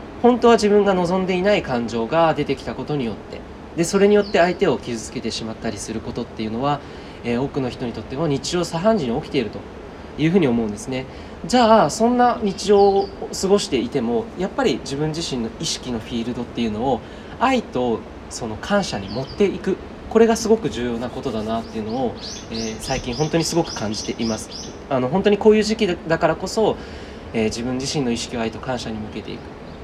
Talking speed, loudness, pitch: 440 characters per minute, -21 LUFS, 145 Hz